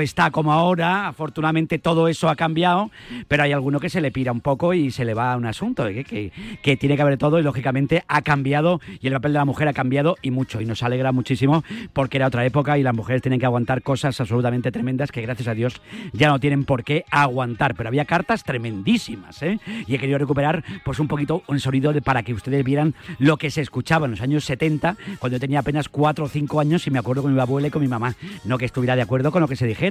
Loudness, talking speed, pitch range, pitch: -21 LUFS, 255 wpm, 130-155 Hz, 145 Hz